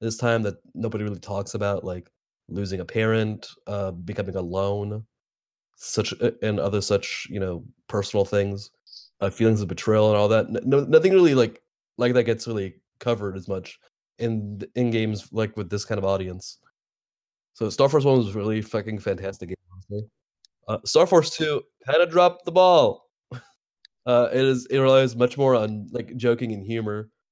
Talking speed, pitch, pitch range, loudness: 170 wpm, 110 Hz, 100-120 Hz, -23 LUFS